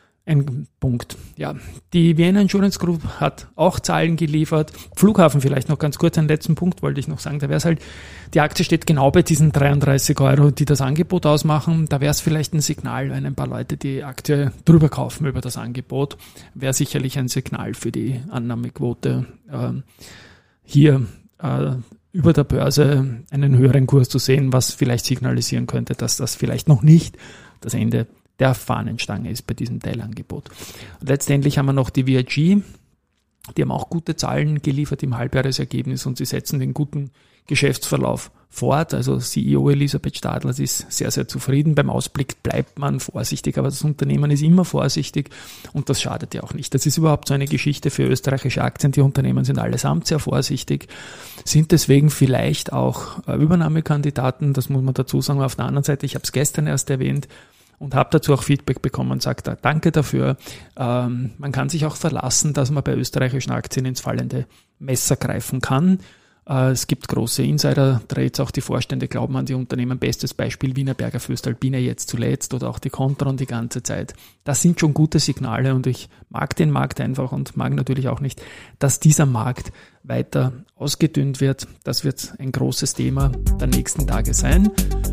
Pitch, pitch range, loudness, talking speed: 135 Hz, 125-150 Hz, -20 LUFS, 180 wpm